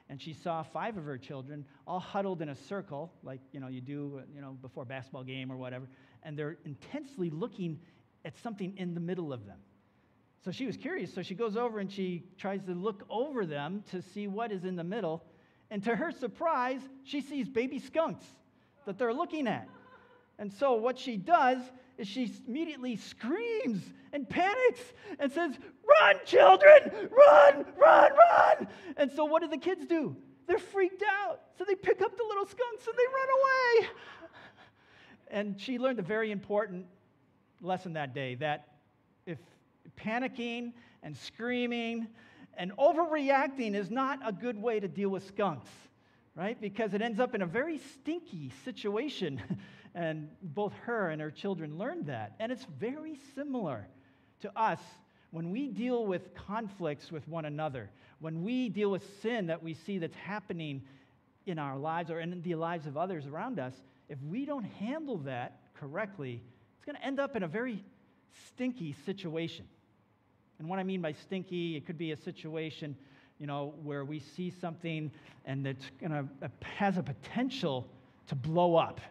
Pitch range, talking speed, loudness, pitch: 155-250 Hz, 175 wpm, -31 LUFS, 195 Hz